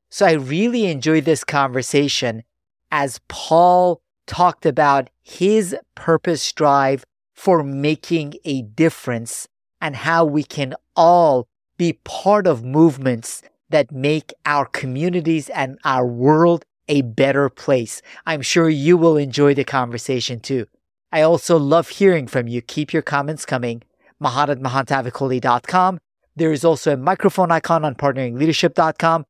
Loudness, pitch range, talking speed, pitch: -18 LUFS, 135-165 Hz, 130 wpm, 150 Hz